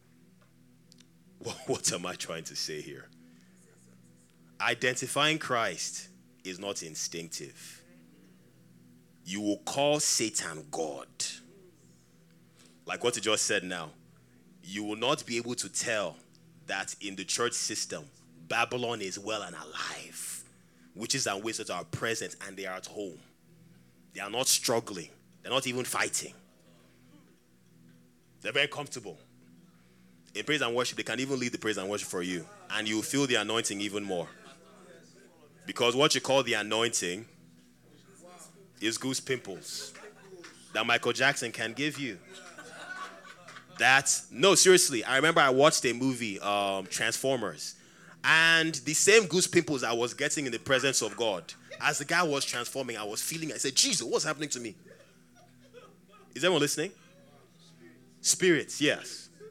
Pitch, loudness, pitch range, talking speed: 110 Hz, -29 LUFS, 85-135 Hz, 145 wpm